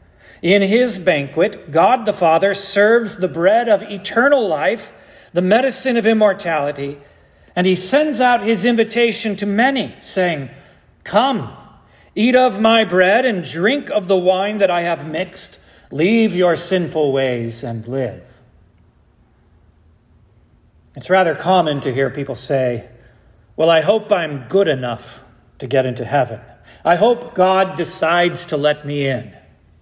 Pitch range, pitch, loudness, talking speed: 135-210 Hz, 175 Hz, -16 LUFS, 140 wpm